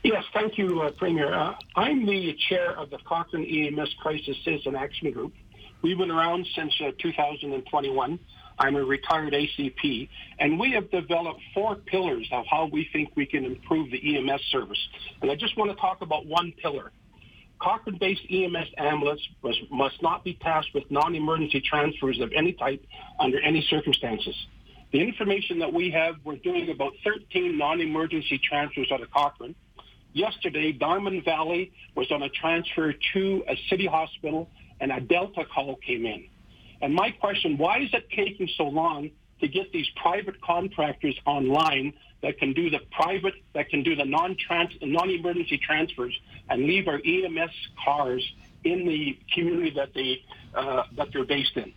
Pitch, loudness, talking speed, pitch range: 160 Hz, -27 LUFS, 160 wpm, 145-185 Hz